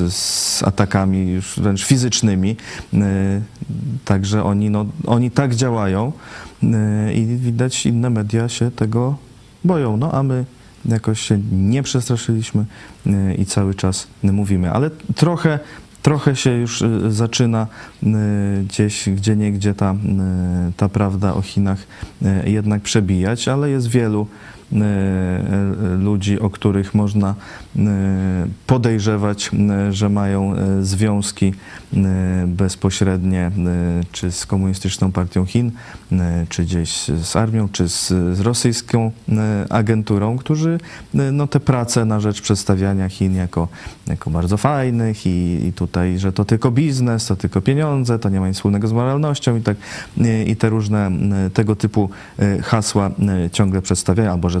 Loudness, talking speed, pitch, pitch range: -18 LUFS, 120 wpm, 105 Hz, 95-115 Hz